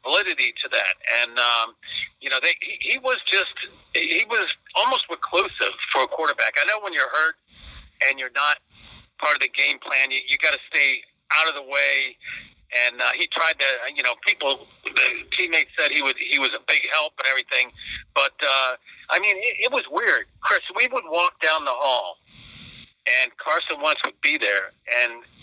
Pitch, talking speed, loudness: 175 Hz, 180 wpm, -21 LUFS